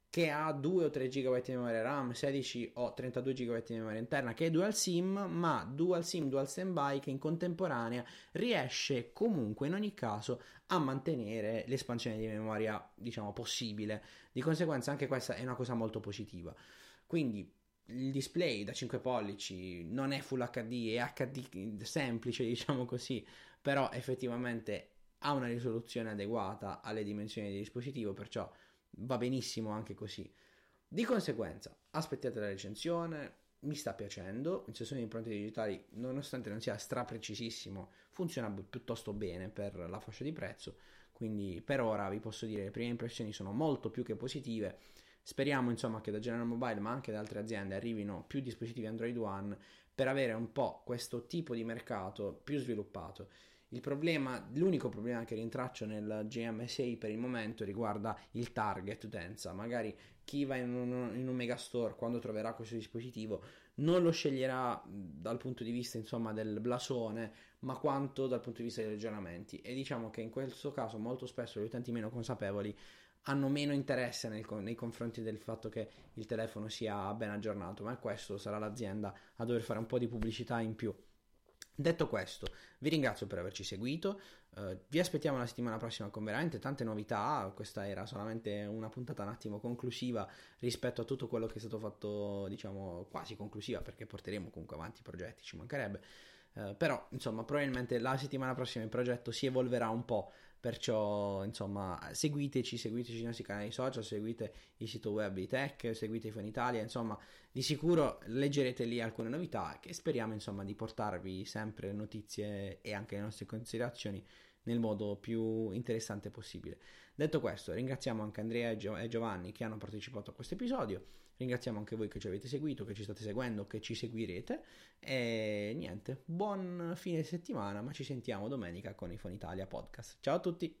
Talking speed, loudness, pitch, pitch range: 170 wpm, -39 LUFS, 115 Hz, 105-130 Hz